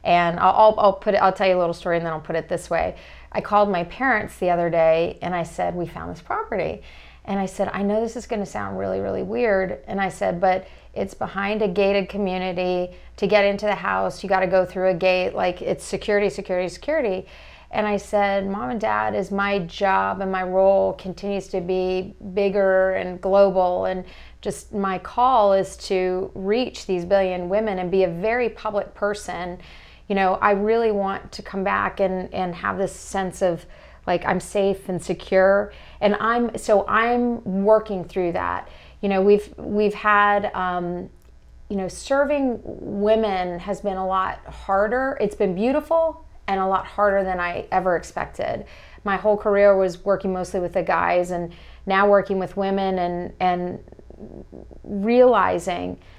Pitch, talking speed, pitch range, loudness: 195 Hz, 190 wpm, 180-205 Hz, -22 LUFS